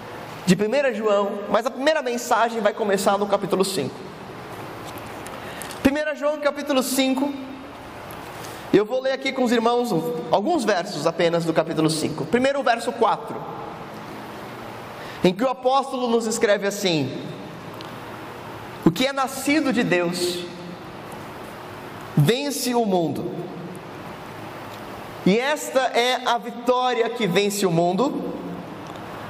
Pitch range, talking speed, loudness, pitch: 180-265 Hz, 120 wpm, -22 LUFS, 230 Hz